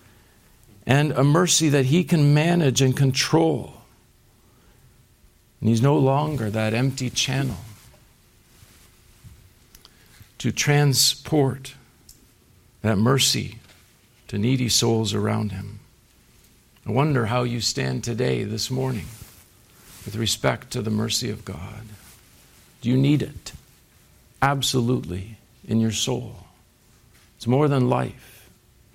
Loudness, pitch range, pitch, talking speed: -22 LUFS, 110-135 Hz, 120 Hz, 110 wpm